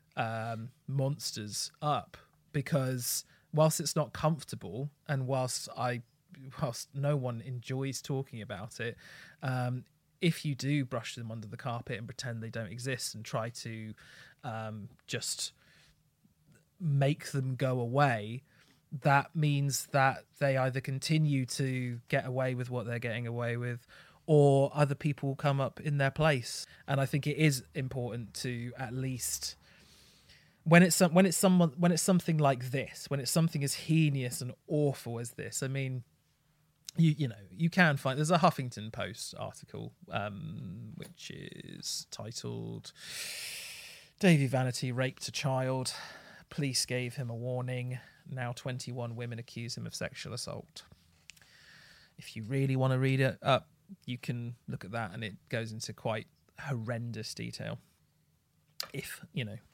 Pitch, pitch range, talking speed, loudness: 135 Hz, 120-150 Hz, 155 wpm, -33 LUFS